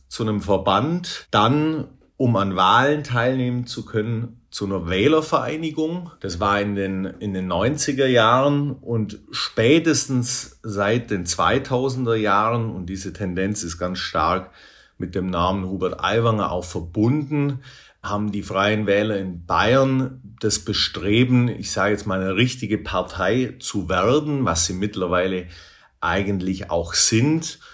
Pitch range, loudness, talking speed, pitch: 95-130 Hz, -21 LUFS, 135 wpm, 105 Hz